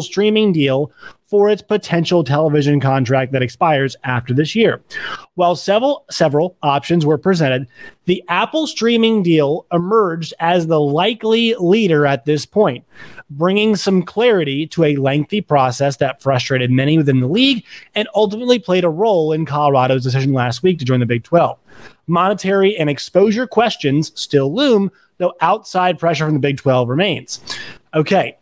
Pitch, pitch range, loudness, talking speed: 165 Hz, 140-200 Hz, -16 LUFS, 155 wpm